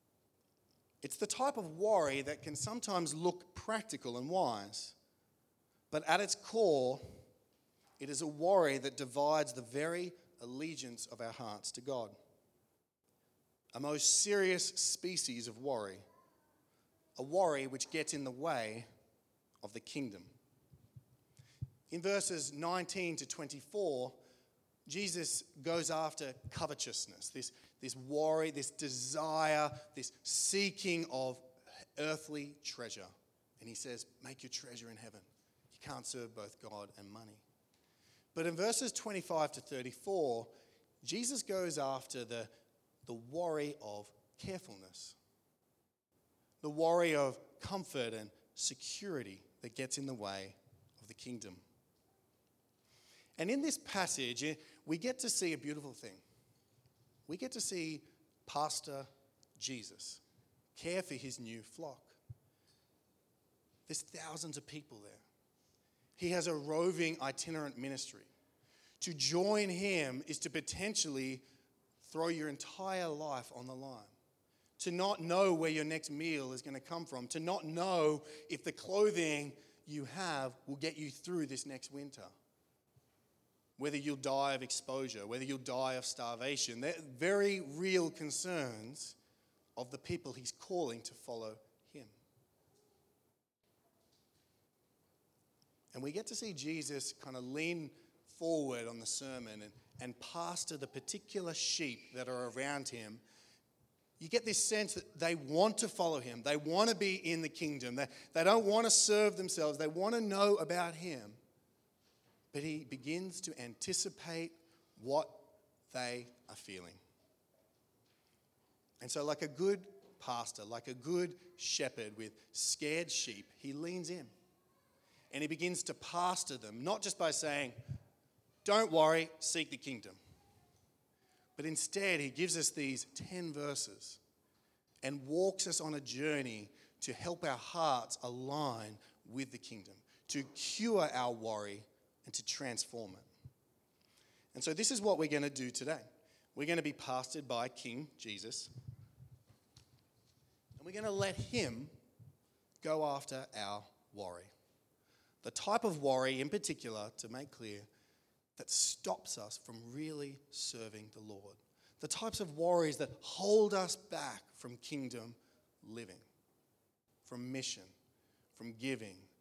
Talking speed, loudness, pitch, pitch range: 135 wpm, -38 LUFS, 140 Hz, 125-165 Hz